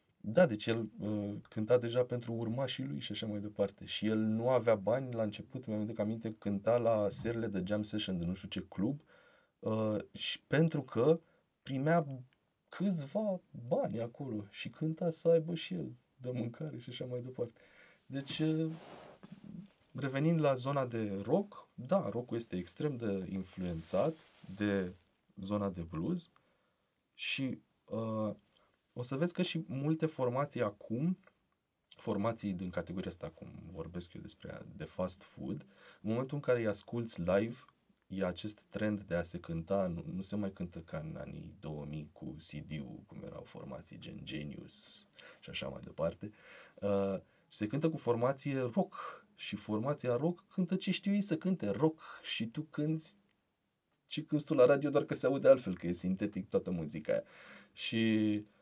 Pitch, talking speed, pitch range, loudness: 115 Hz, 165 wpm, 100-150 Hz, -36 LUFS